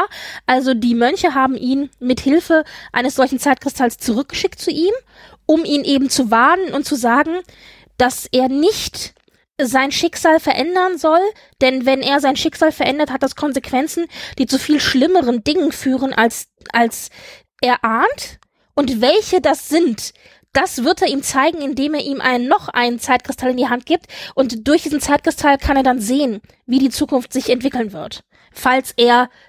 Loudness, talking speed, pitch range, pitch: -16 LUFS, 170 wpm, 255-315 Hz, 275 Hz